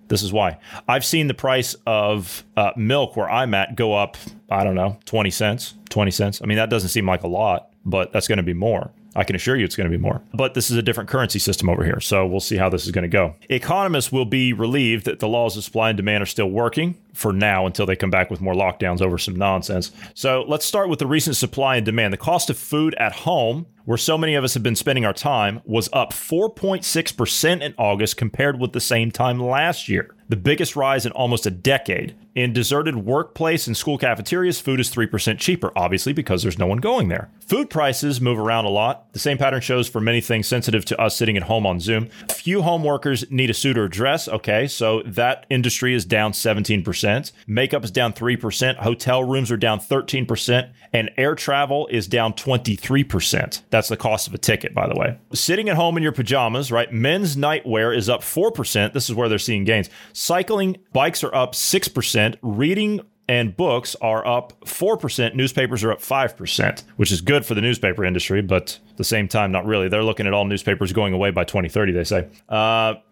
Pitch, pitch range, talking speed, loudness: 115 Hz, 105-135 Hz, 220 wpm, -20 LUFS